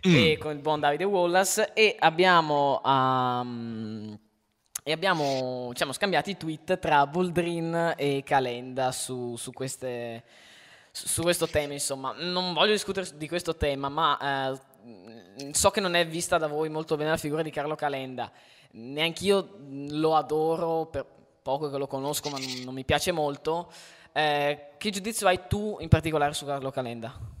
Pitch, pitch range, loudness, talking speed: 150 Hz, 130-170 Hz, -27 LUFS, 155 wpm